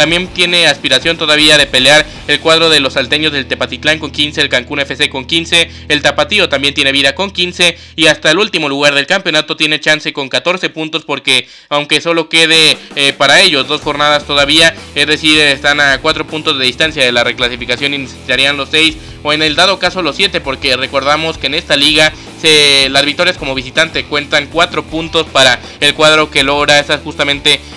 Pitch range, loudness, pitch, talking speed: 140-160 Hz, -9 LUFS, 150 Hz, 200 wpm